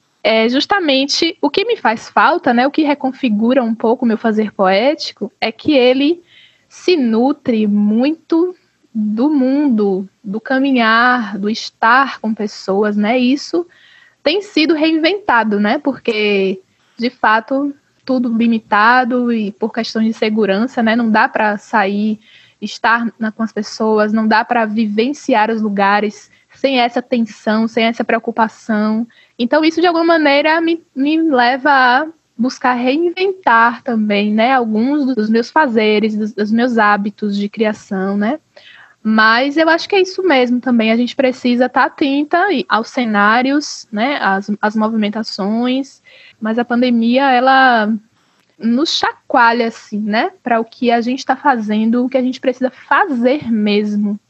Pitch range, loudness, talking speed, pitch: 220-275 Hz, -14 LUFS, 150 wpm, 240 Hz